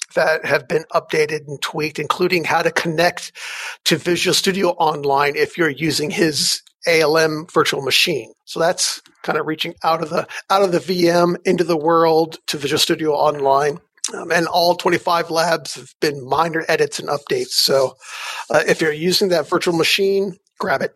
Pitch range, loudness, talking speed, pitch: 155-180 Hz, -18 LUFS, 175 wpm, 165 Hz